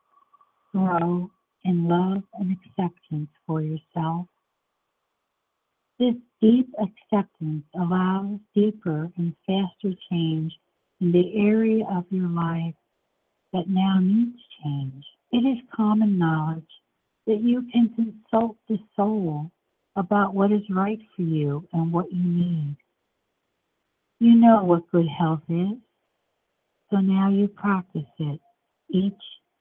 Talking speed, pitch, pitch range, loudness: 120 wpm, 190 Hz, 170-215 Hz, -24 LUFS